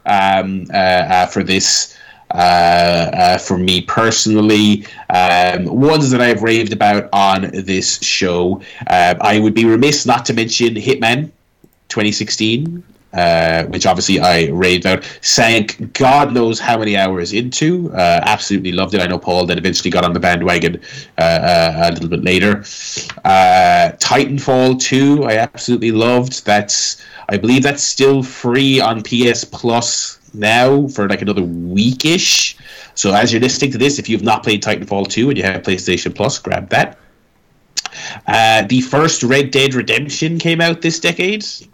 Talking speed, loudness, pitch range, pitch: 160 wpm, -13 LUFS, 95-130 Hz, 110 Hz